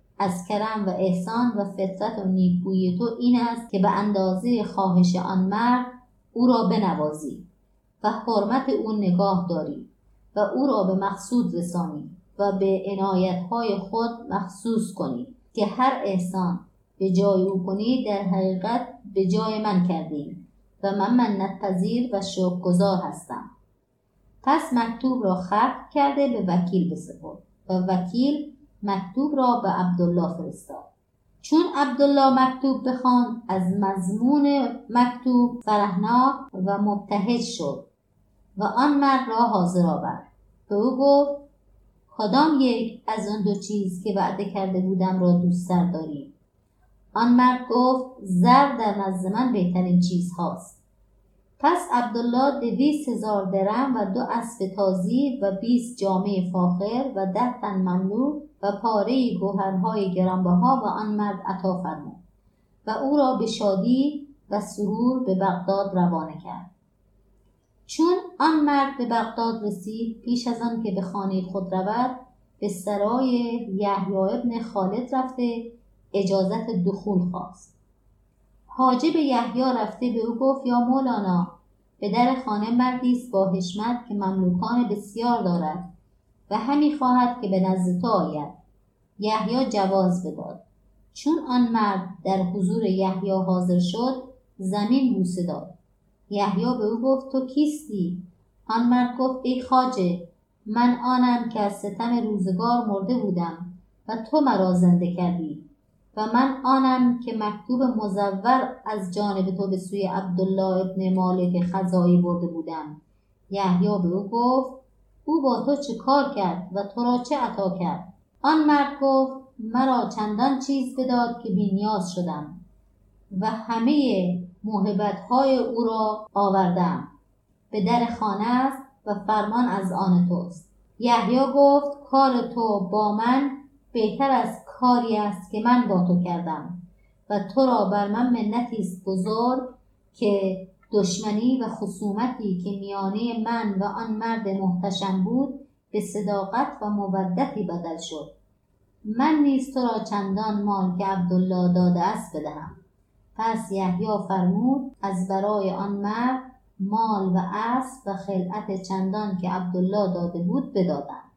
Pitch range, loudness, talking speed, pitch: 190-245 Hz, -24 LUFS, 135 wpm, 205 Hz